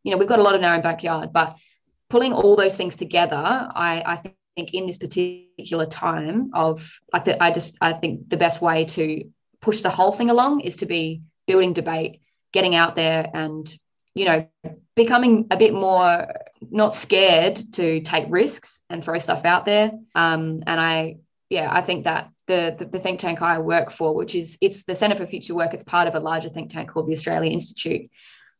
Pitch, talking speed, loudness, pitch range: 175 Hz, 205 wpm, -21 LUFS, 165-190 Hz